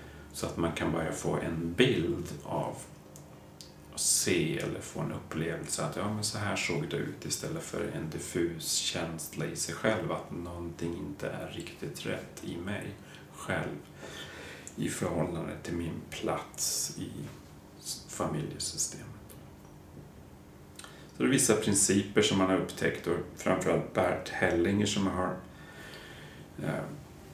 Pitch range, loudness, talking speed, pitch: 75-95 Hz, -32 LUFS, 140 wpm, 85 Hz